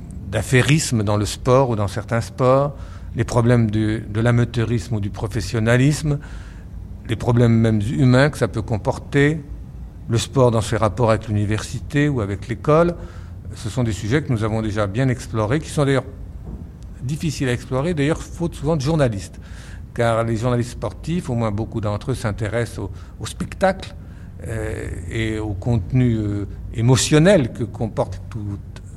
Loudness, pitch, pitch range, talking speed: -20 LUFS, 115 Hz, 105-125 Hz, 160 wpm